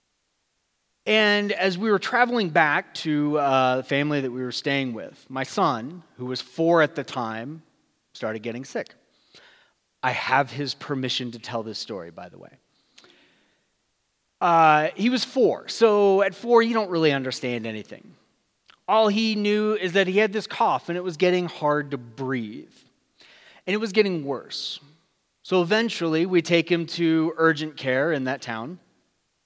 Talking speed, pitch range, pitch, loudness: 165 wpm, 130-195 Hz, 160 Hz, -23 LUFS